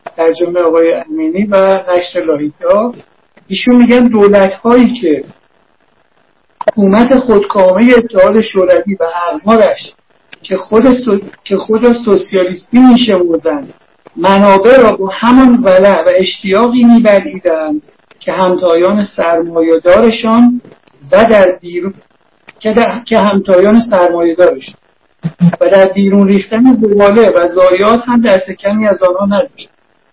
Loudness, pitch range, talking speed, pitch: -9 LUFS, 180-230 Hz, 115 wpm, 195 Hz